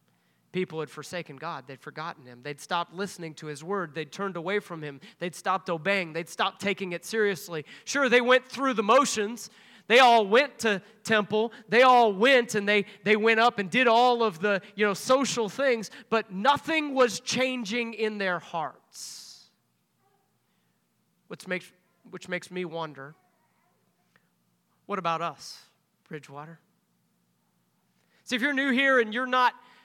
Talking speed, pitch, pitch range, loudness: 160 wpm, 205 Hz, 170-240 Hz, -25 LUFS